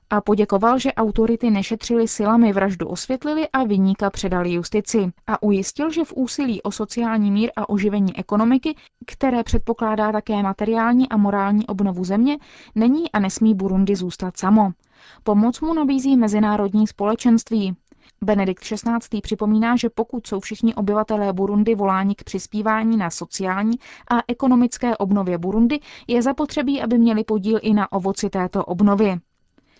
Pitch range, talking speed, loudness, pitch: 200-235 Hz, 140 wpm, -20 LUFS, 215 Hz